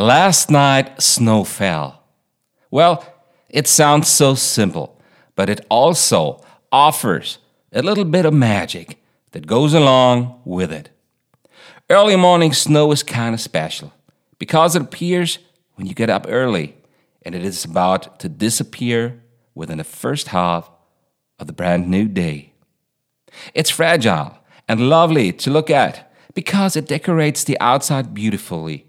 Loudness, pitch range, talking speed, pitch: -16 LUFS, 105-165 Hz, 135 wpm, 135 Hz